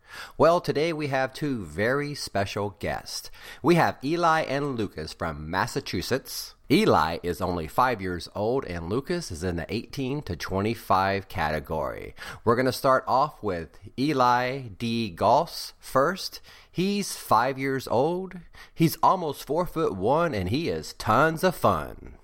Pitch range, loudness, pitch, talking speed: 90-140 Hz, -26 LUFS, 115 Hz, 150 wpm